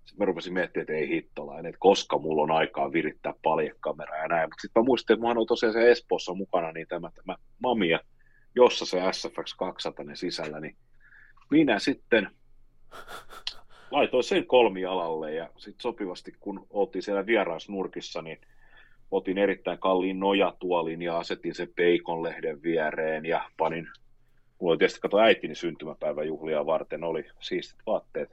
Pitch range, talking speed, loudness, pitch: 85-120 Hz, 145 wpm, -27 LUFS, 95 Hz